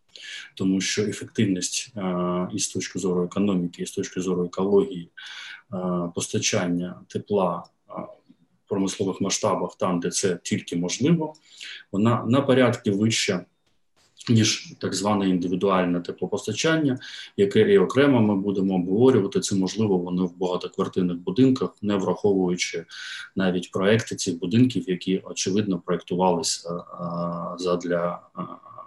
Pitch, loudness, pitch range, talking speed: 95 Hz, -24 LUFS, 90-110 Hz, 115 wpm